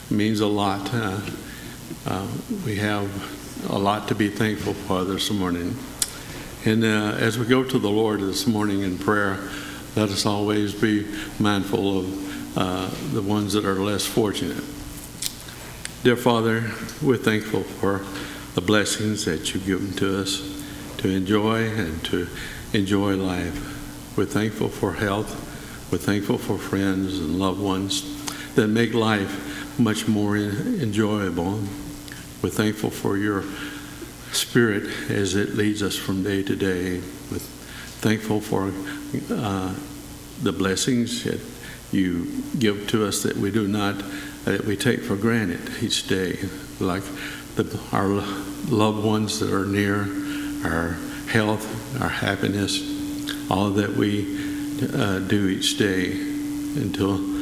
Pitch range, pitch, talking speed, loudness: 95-110 Hz, 105 Hz, 135 wpm, -24 LUFS